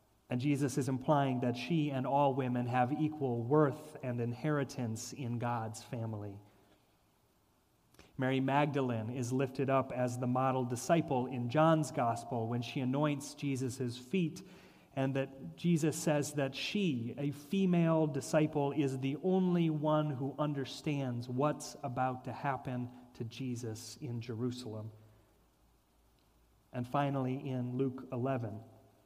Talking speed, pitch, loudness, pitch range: 130 wpm, 135 Hz, -35 LUFS, 125-145 Hz